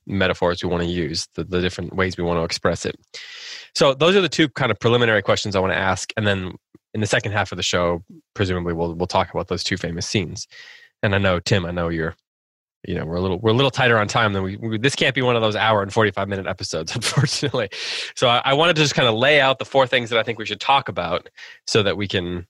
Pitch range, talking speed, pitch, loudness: 90-125 Hz, 270 wpm, 100 Hz, -20 LUFS